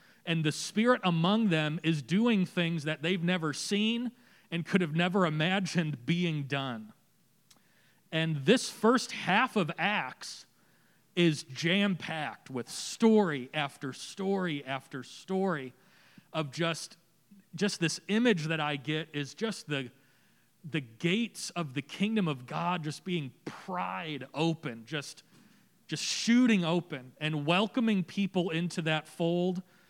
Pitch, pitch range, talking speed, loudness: 170 Hz, 155-200 Hz, 130 wpm, -31 LUFS